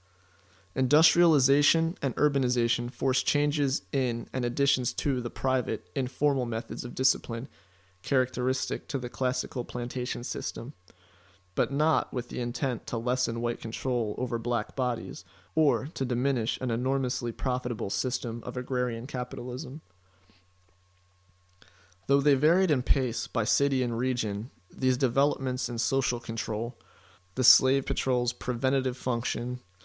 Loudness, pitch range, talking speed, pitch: -28 LUFS, 115-135 Hz, 125 wpm, 125 Hz